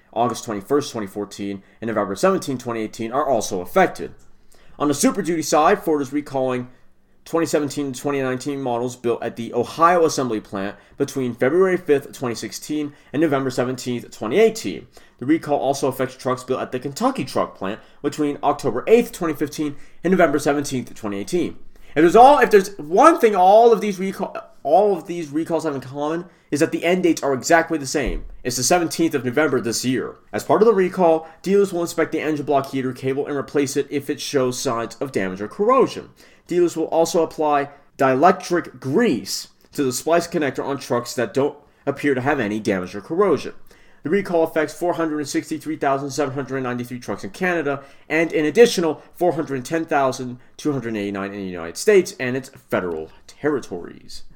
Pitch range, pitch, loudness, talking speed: 125-165 Hz, 145 Hz, -20 LUFS, 170 wpm